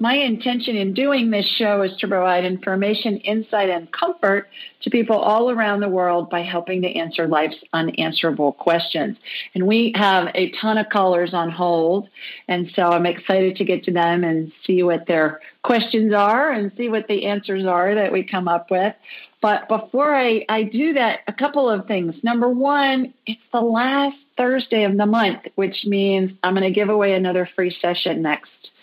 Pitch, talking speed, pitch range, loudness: 200 Hz, 185 wpm, 180-225 Hz, -19 LUFS